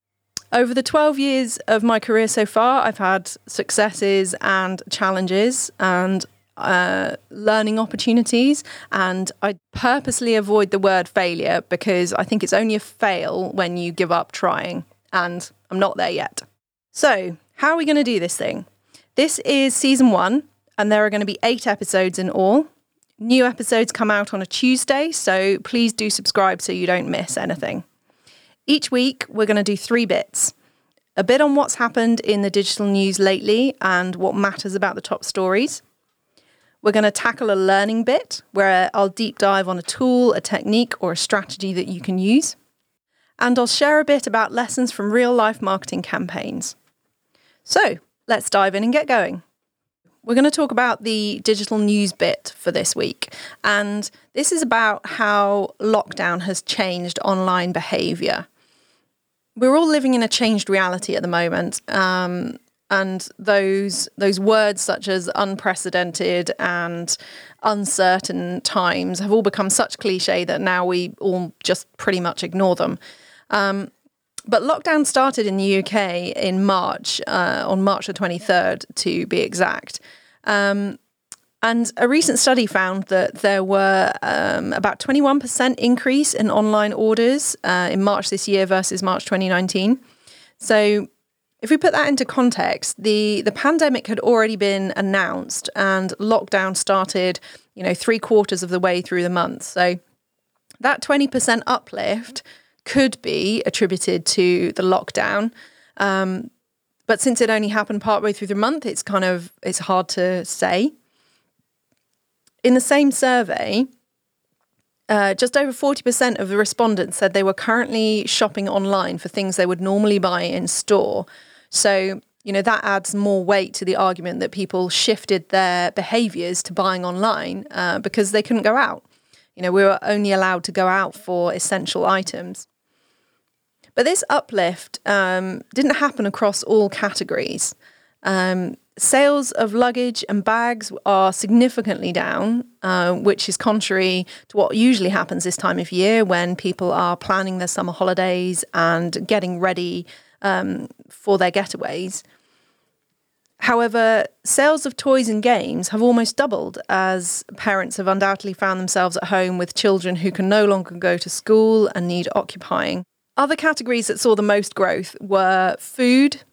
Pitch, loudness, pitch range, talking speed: 205 Hz, -19 LUFS, 190-235 Hz, 160 wpm